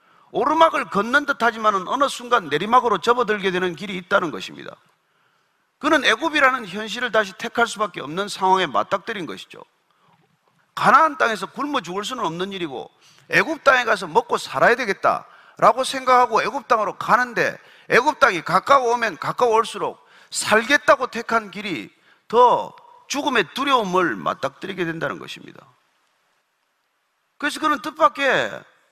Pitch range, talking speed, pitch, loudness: 205-290 Hz, 330 characters per minute, 240 Hz, -20 LUFS